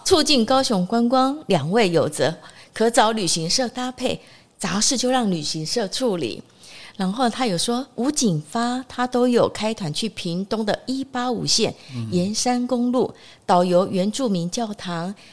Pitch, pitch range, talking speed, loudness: 225 Hz, 180-250 Hz, 225 characters per minute, -21 LUFS